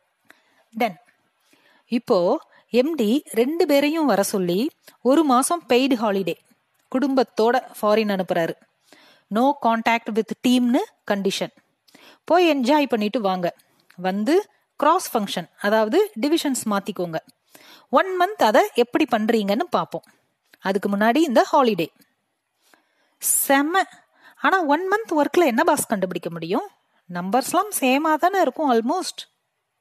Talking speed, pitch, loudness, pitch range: 105 wpm, 255 Hz, -21 LUFS, 215-315 Hz